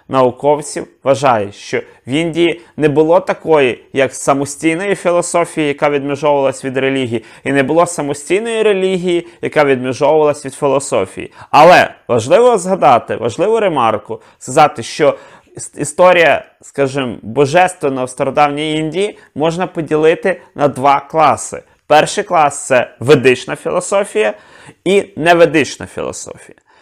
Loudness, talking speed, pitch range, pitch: -13 LUFS, 110 wpm, 140-175 Hz, 150 Hz